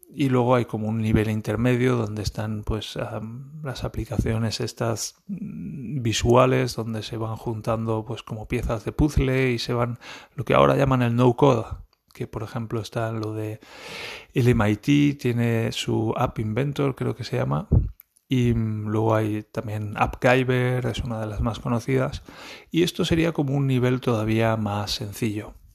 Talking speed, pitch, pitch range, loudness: 165 wpm, 115 Hz, 110-130 Hz, -24 LUFS